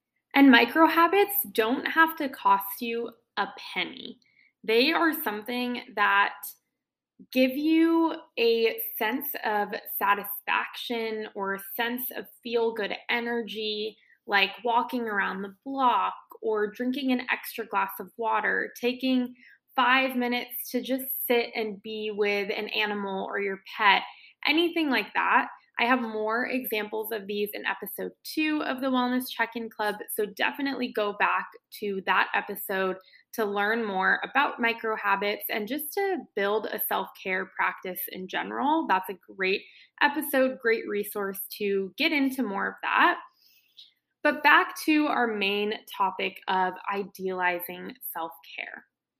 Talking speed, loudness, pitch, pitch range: 140 wpm, -27 LUFS, 230 Hz, 205-265 Hz